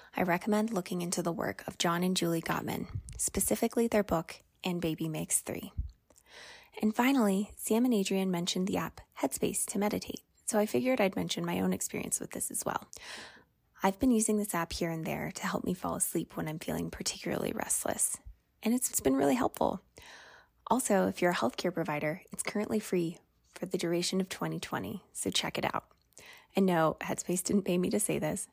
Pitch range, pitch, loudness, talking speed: 170-210 Hz, 185 Hz, -32 LUFS, 190 wpm